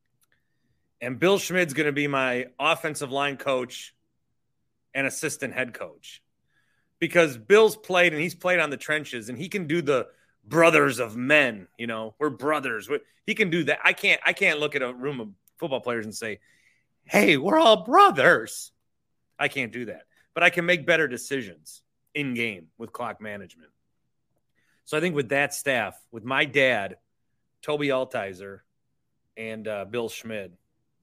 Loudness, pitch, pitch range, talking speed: -23 LUFS, 145 Hz, 125-170 Hz, 165 wpm